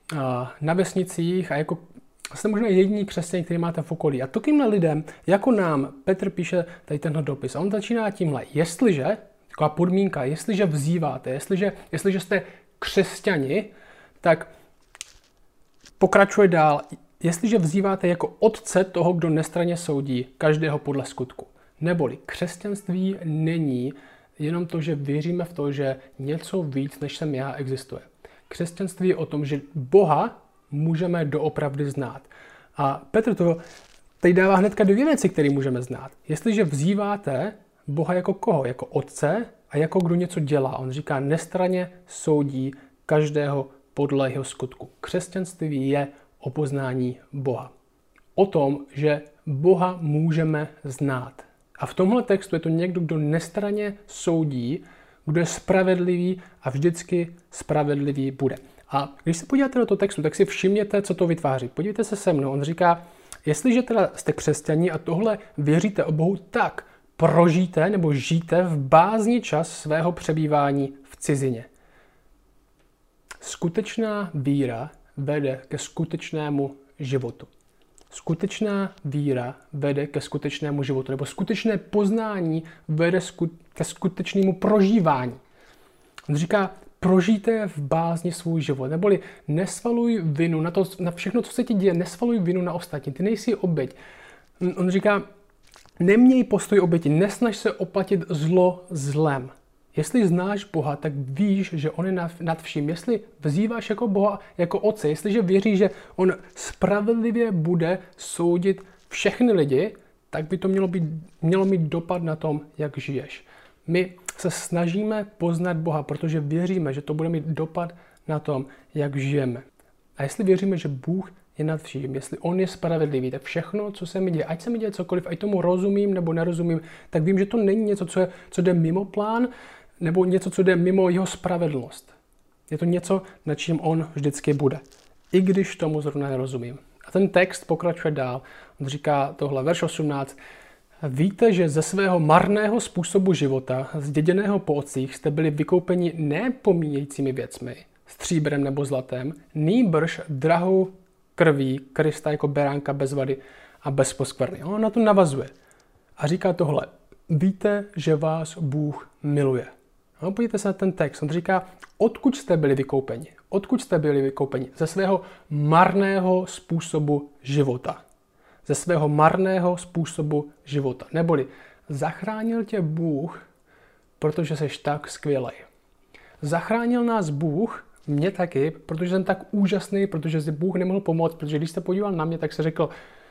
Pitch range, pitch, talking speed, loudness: 145-190 Hz, 165 Hz, 145 wpm, -24 LUFS